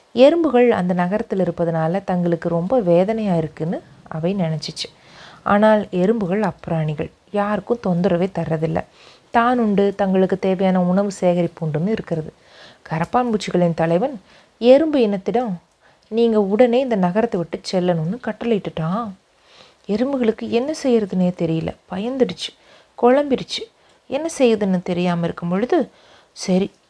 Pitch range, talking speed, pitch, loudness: 175-230 Hz, 105 wpm, 195 Hz, -19 LUFS